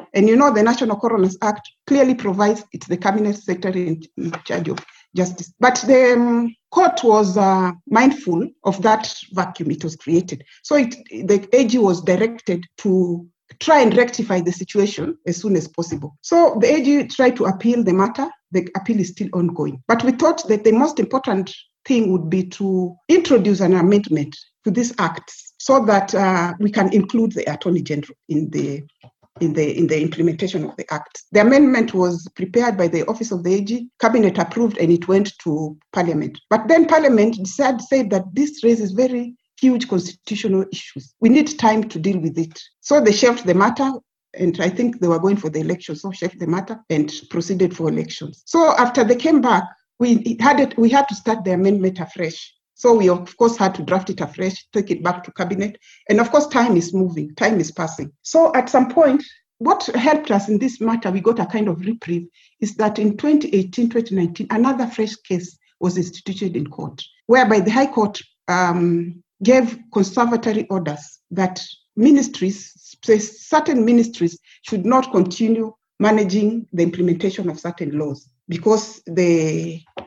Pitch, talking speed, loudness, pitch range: 205 Hz, 180 wpm, -18 LUFS, 175-235 Hz